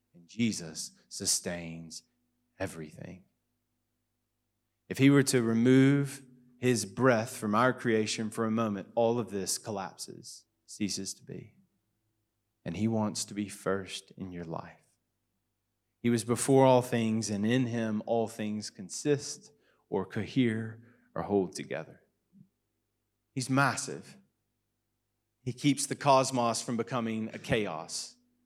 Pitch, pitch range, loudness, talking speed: 115 Hz, 105-125 Hz, -30 LUFS, 120 wpm